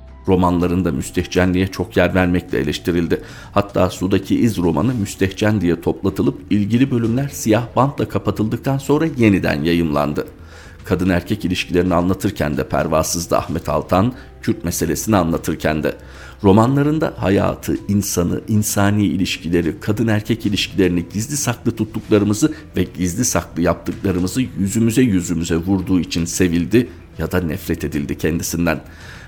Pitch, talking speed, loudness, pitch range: 95 Hz, 120 wpm, -18 LUFS, 85-110 Hz